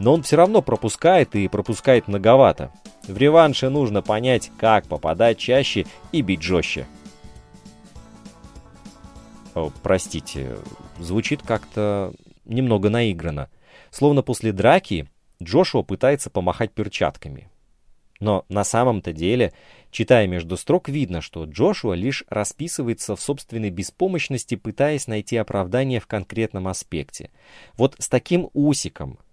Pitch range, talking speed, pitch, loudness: 100-135 Hz, 115 wpm, 110 Hz, -21 LUFS